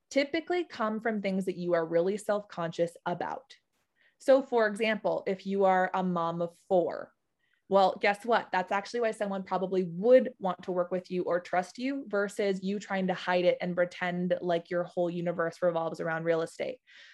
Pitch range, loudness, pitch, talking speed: 175-220 Hz, -30 LUFS, 190 Hz, 190 wpm